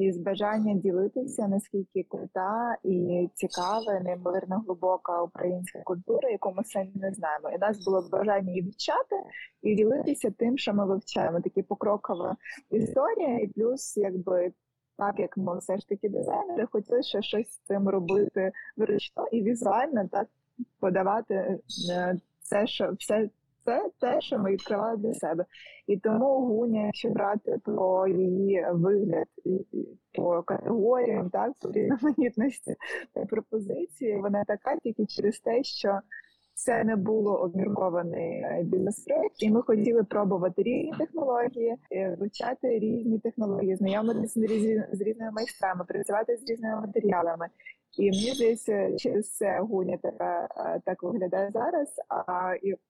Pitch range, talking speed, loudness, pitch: 190-230 Hz, 135 wpm, -29 LUFS, 205 Hz